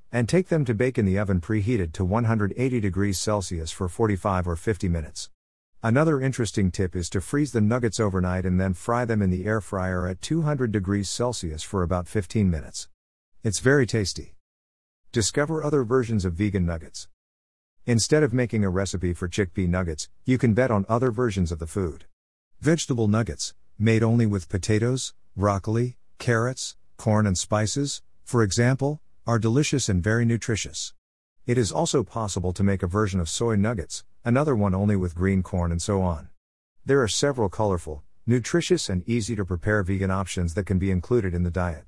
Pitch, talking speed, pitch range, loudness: 100 Hz, 180 wpm, 90-120 Hz, -25 LUFS